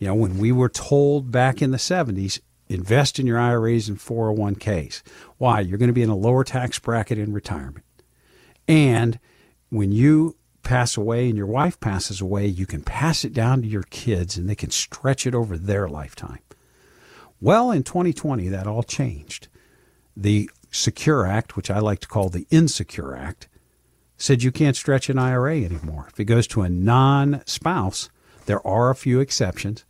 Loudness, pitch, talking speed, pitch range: -21 LUFS, 115 Hz, 180 wpm, 100-130 Hz